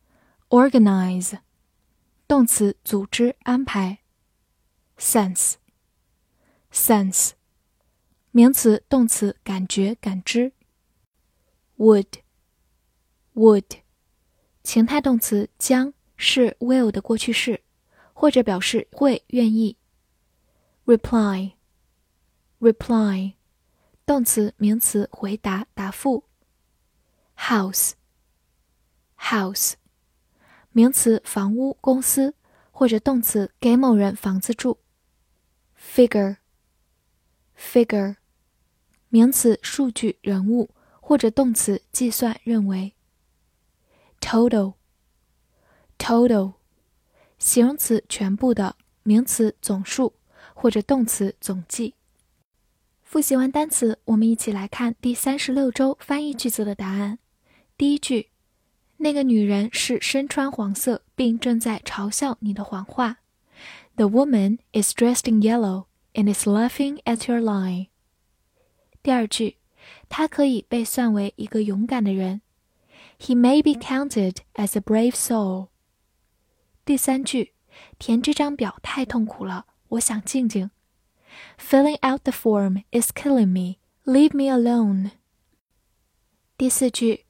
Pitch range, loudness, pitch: 200-250 Hz, -21 LUFS, 225 Hz